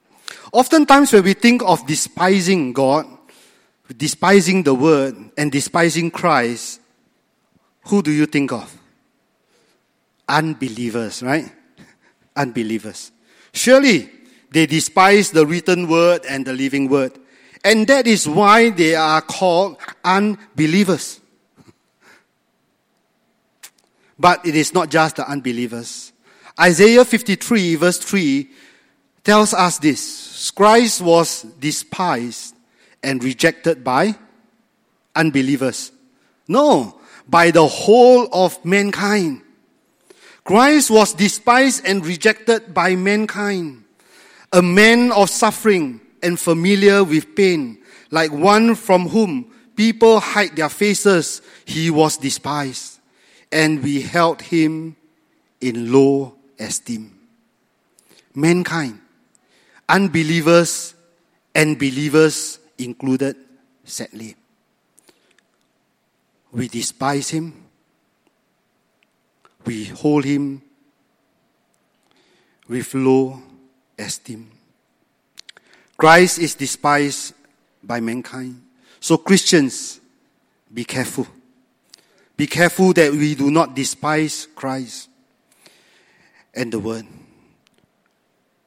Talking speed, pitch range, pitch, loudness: 90 wpm, 140-205 Hz, 165 Hz, -16 LUFS